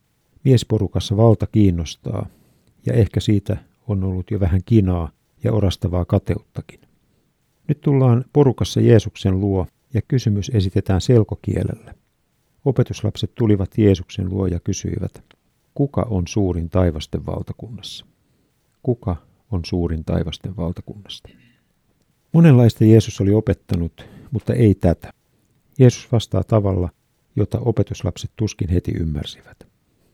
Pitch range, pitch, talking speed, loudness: 95-115 Hz, 105 Hz, 110 wpm, -19 LUFS